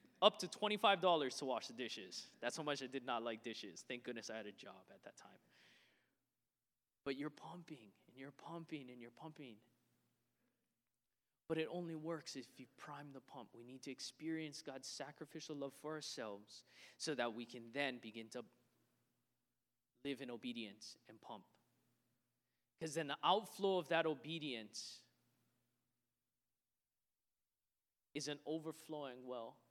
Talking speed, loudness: 150 wpm, -44 LUFS